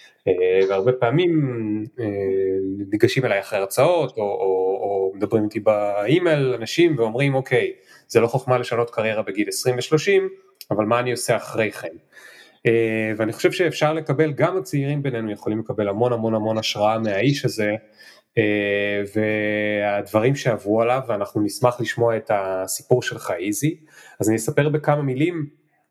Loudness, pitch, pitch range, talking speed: -21 LUFS, 115 Hz, 105-145 Hz, 145 wpm